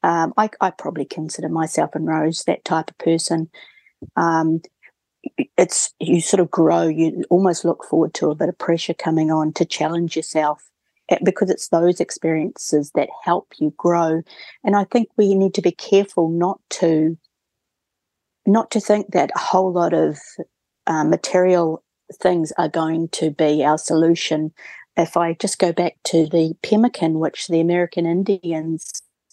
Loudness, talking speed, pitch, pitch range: -19 LUFS, 160 wpm, 170 Hz, 160-185 Hz